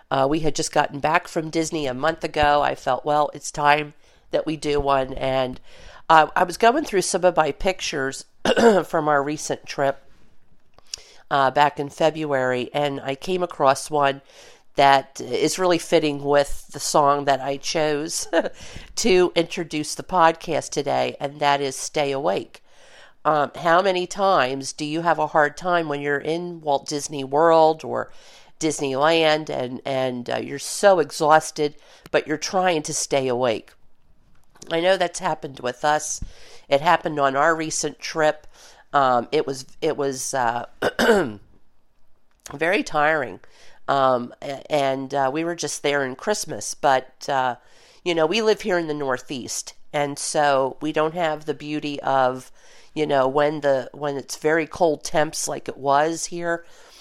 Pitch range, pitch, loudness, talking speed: 140-165 Hz, 150 Hz, -22 LUFS, 160 wpm